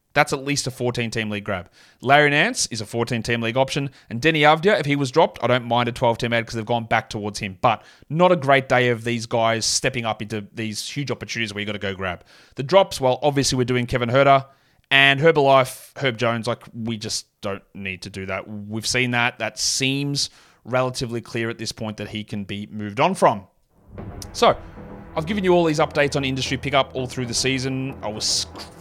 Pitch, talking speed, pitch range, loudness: 120 Hz, 230 wpm, 110-135 Hz, -21 LUFS